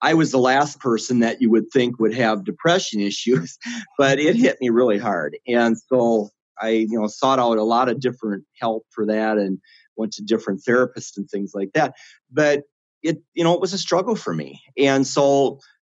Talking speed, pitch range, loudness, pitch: 205 wpm, 110-140 Hz, -20 LUFS, 120 Hz